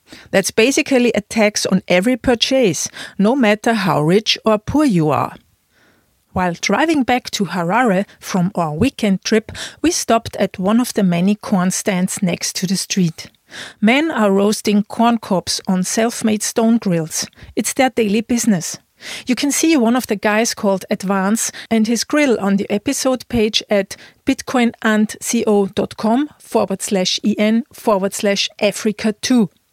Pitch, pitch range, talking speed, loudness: 215 Hz, 195-235 Hz, 150 wpm, -17 LUFS